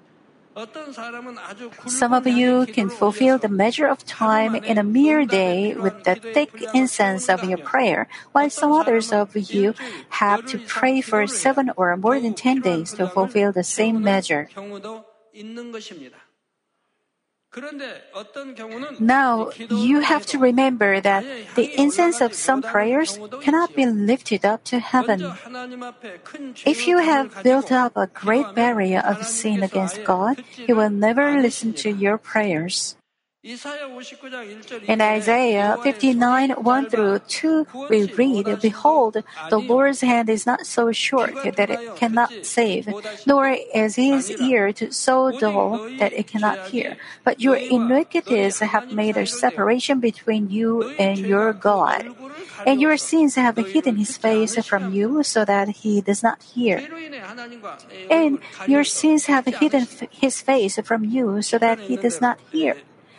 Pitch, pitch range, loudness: 235 Hz, 210-265 Hz, -20 LUFS